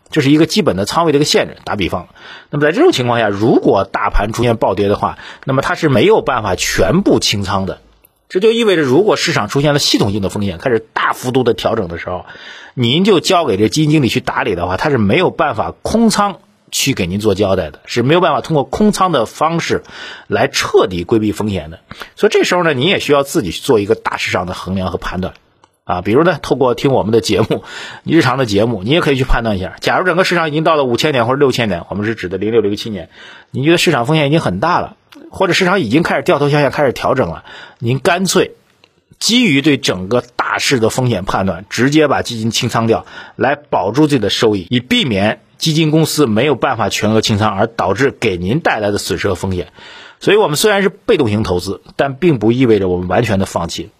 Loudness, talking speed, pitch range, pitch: -14 LUFS, 355 characters per minute, 105-155 Hz, 125 Hz